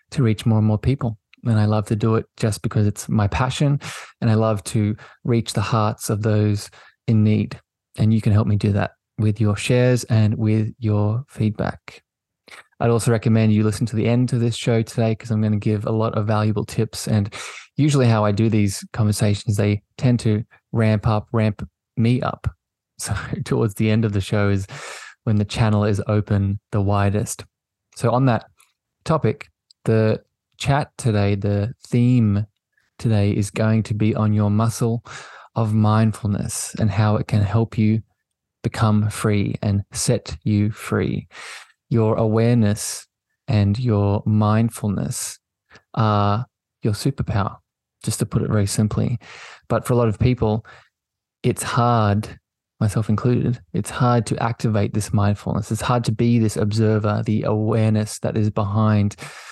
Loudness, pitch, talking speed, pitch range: -21 LUFS, 110 Hz, 165 wpm, 105-115 Hz